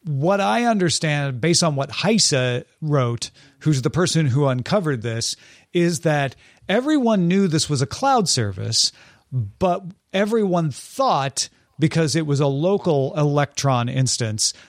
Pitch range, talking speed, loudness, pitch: 135-180 Hz, 135 wpm, -20 LUFS, 150 Hz